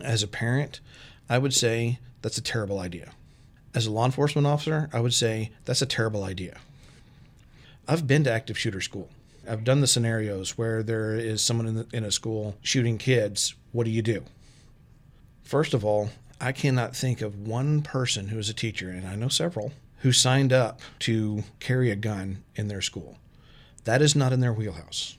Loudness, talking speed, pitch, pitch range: -26 LUFS, 190 wpm, 115 Hz, 110-130 Hz